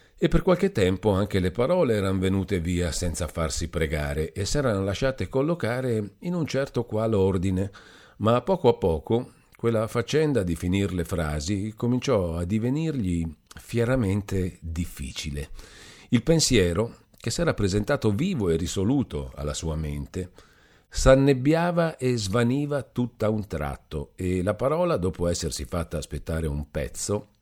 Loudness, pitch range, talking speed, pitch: -26 LUFS, 85-125 Hz, 140 wpm, 100 Hz